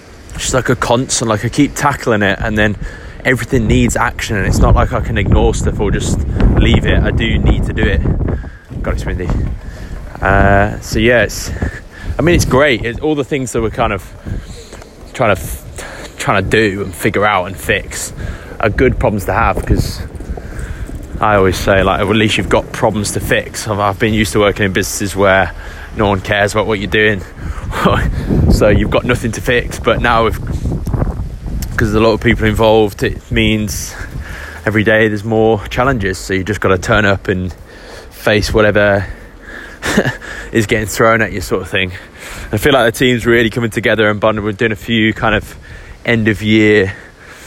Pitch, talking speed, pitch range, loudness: 105 Hz, 190 wpm, 95-115 Hz, -14 LUFS